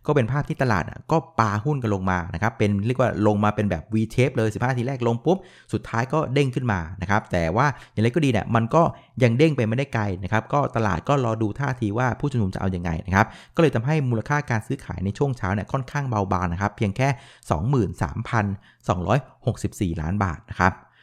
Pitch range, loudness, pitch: 100-135 Hz, -23 LUFS, 115 Hz